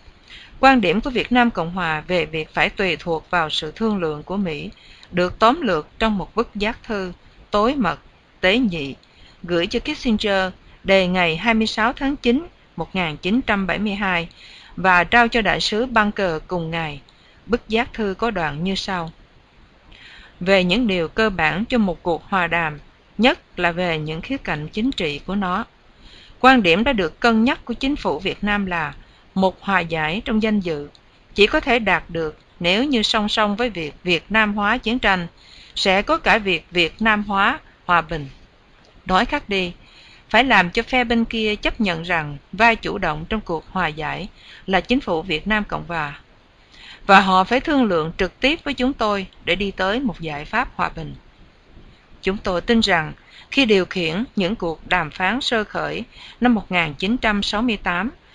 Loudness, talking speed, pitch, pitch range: -20 LUFS, 185 wpm, 195 Hz, 170-230 Hz